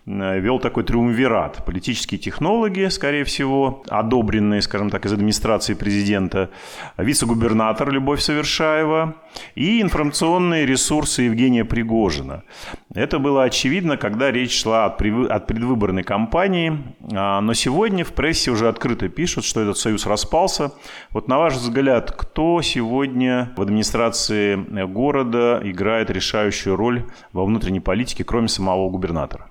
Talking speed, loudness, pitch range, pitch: 120 wpm, -19 LUFS, 105-140 Hz, 120 Hz